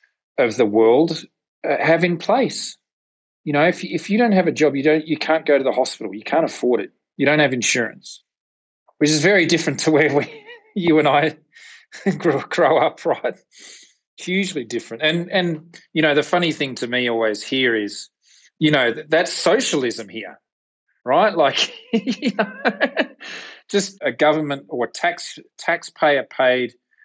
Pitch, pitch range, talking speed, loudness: 160 Hz, 145-195 Hz, 175 wpm, -19 LUFS